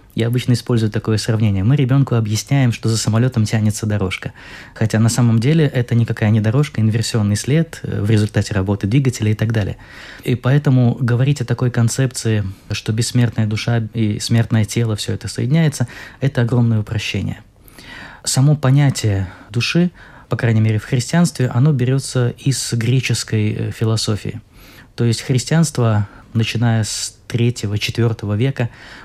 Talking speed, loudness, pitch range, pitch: 140 wpm, -17 LUFS, 110-125 Hz, 115 Hz